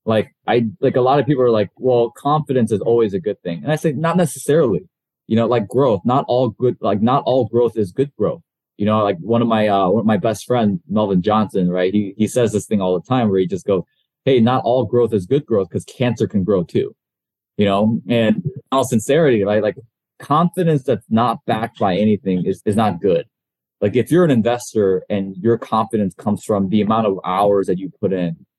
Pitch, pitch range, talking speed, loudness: 110 Hz, 100-125 Hz, 230 wpm, -18 LUFS